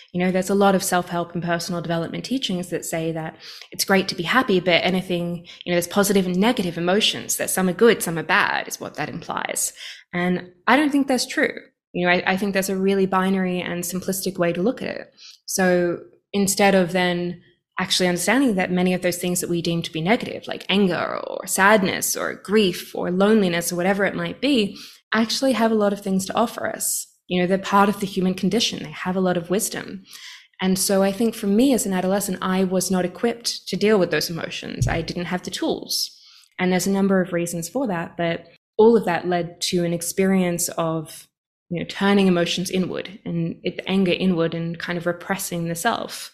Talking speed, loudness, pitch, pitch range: 220 wpm, -21 LUFS, 185 Hz, 175-200 Hz